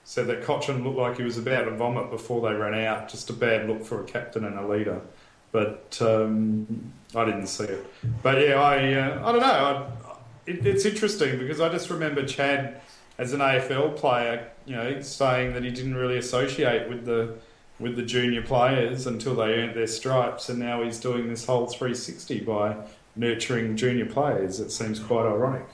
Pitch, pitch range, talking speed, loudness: 120 Hz, 115-135 Hz, 195 wpm, -26 LUFS